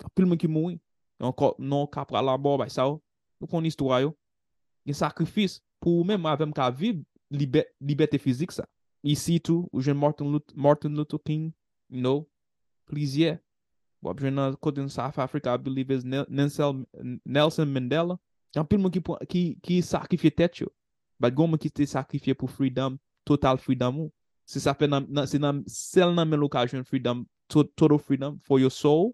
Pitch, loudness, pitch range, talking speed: 145 Hz, -26 LUFS, 135-160 Hz, 70 wpm